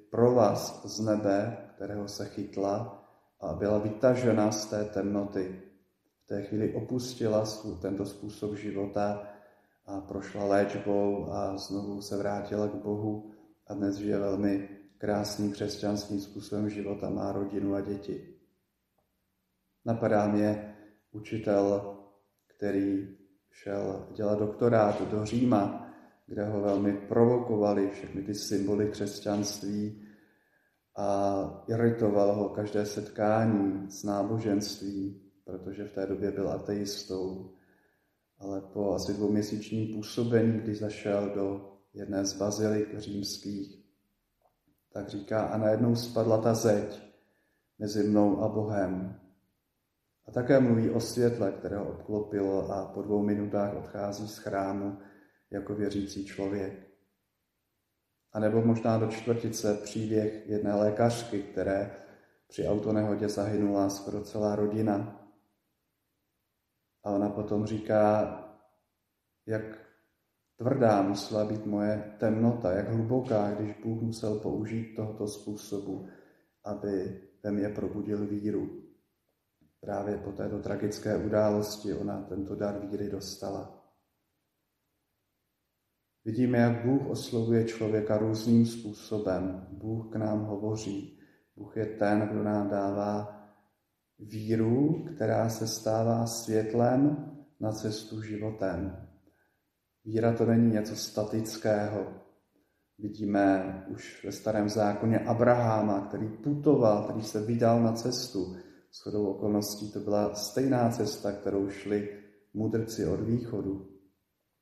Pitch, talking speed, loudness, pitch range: 105 Hz, 115 wpm, -30 LUFS, 100-110 Hz